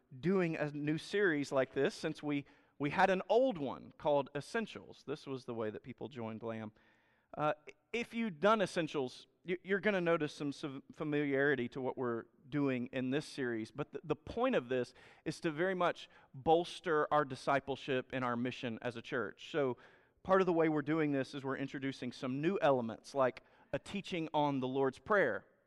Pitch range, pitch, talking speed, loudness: 130-165 Hz, 145 Hz, 190 wpm, -36 LUFS